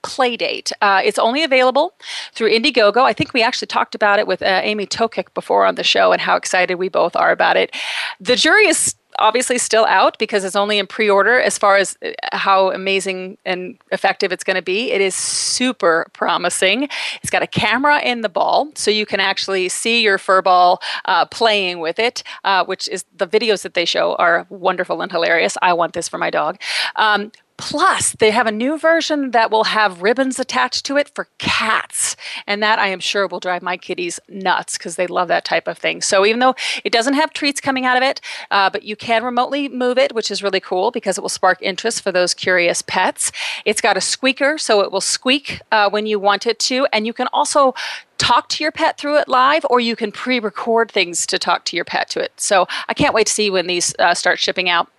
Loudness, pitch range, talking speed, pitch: -16 LUFS, 190-255 Hz, 225 wpm, 215 Hz